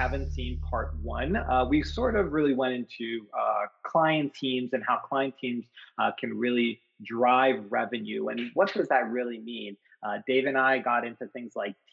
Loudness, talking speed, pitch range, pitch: -28 LUFS, 185 wpm, 115-130 Hz, 125 Hz